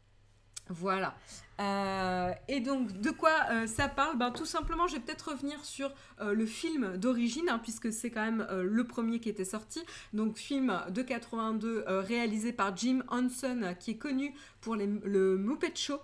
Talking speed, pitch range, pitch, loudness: 185 wpm, 200-275 Hz, 230 Hz, -33 LUFS